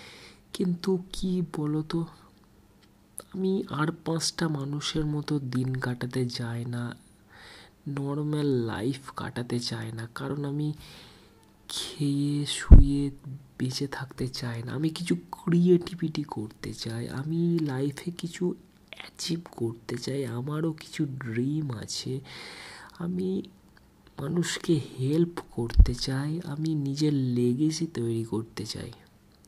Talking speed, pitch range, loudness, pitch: 105 wpm, 120-165 Hz, -29 LUFS, 140 Hz